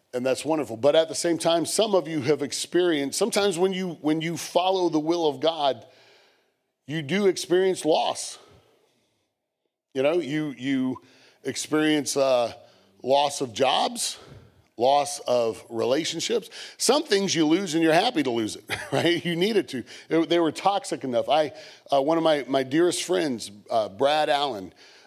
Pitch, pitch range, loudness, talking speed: 160 Hz, 140-175 Hz, -24 LUFS, 165 wpm